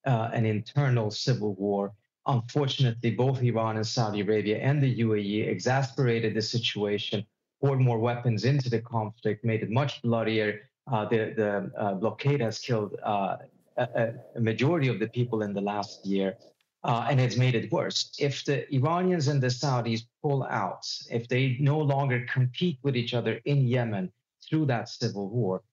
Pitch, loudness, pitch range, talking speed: 120 Hz, -28 LUFS, 110-135 Hz, 170 wpm